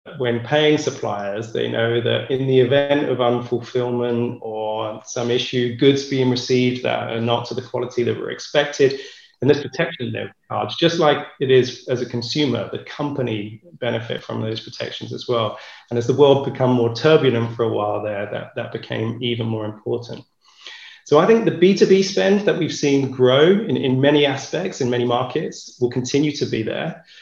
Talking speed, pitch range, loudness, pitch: 185 wpm, 115-145 Hz, -20 LUFS, 125 Hz